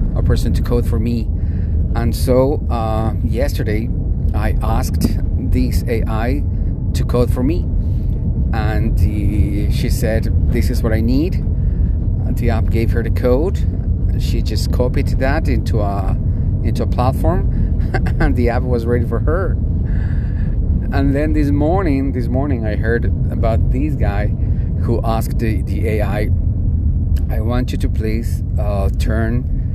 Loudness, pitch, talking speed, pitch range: -18 LUFS, 90 Hz, 145 wpm, 85-110 Hz